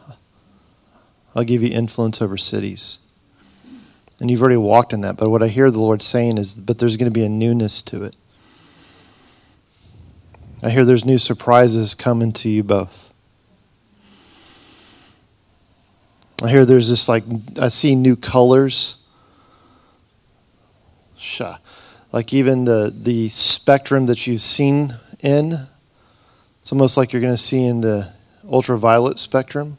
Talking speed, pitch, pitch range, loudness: 135 wpm, 115 Hz, 105-125 Hz, -16 LUFS